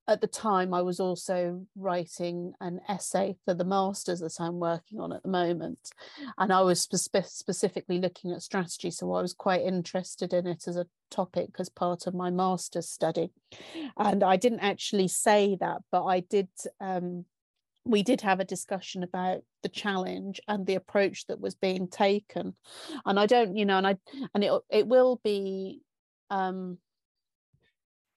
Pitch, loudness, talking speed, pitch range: 190 Hz, -29 LUFS, 175 wpm, 180-200 Hz